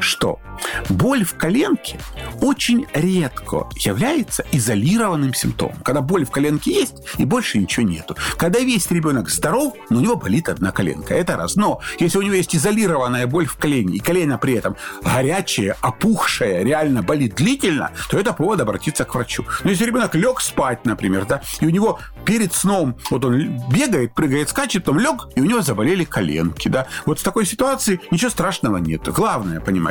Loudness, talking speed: -19 LUFS, 175 wpm